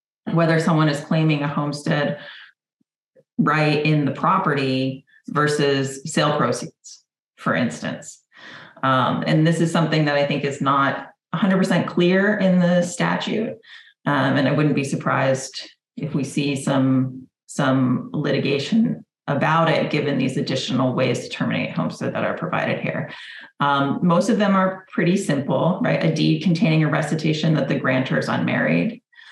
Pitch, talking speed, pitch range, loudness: 150 Hz, 150 wpm, 140-175 Hz, -20 LUFS